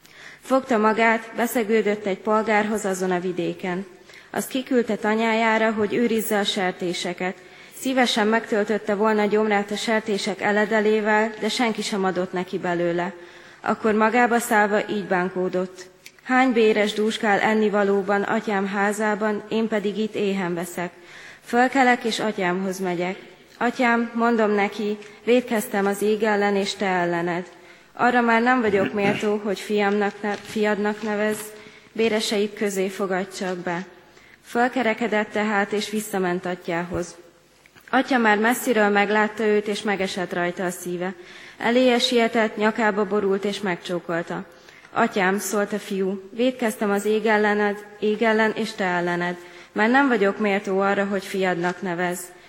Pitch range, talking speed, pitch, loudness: 185-220 Hz, 135 wpm, 210 Hz, -22 LUFS